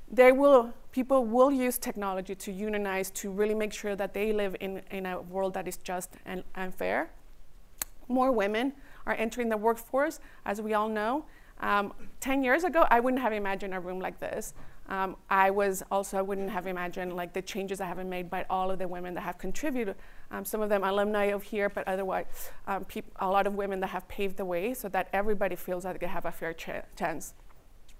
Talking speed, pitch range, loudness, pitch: 215 wpm, 190-220 Hz, -30 LUFS, 200 Hz